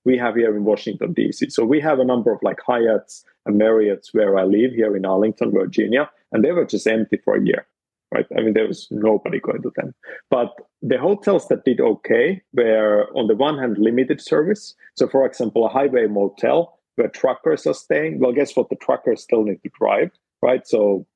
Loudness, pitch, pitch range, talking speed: -19 LUFS, 110 Hz, 105-120 Hz, 210 wpm